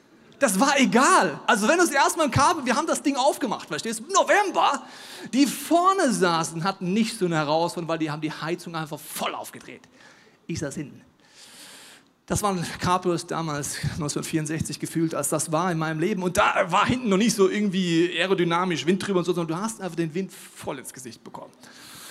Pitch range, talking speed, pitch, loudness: 165-225 Hz, 195 wpm, 185 Hz, -23 LUFS